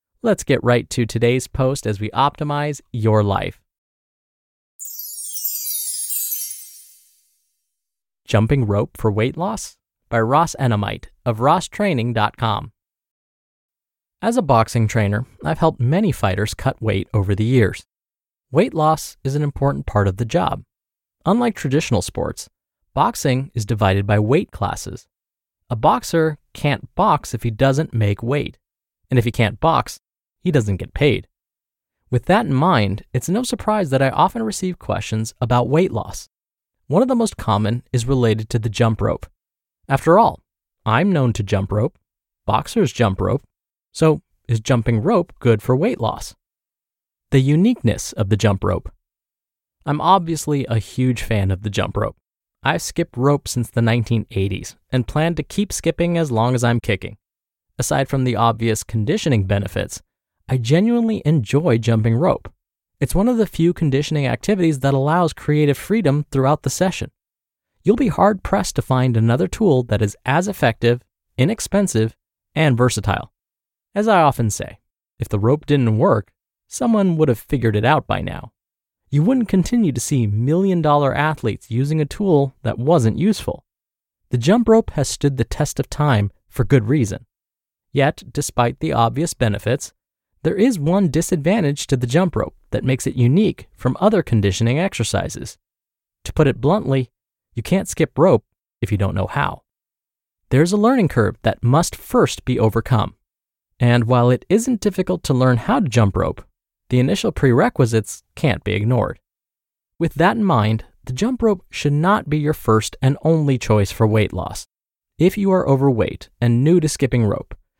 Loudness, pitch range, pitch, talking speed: -19 LUFS, 110-155 Hz, 125 Hz, 160 wpm